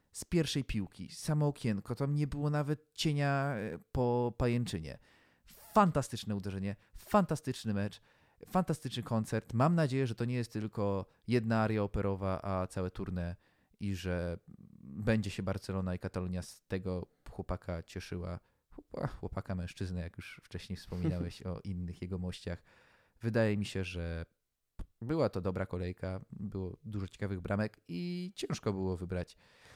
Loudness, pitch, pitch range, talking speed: -36 LUFS, 100 Hz, 90-120 Hz, 135 wpm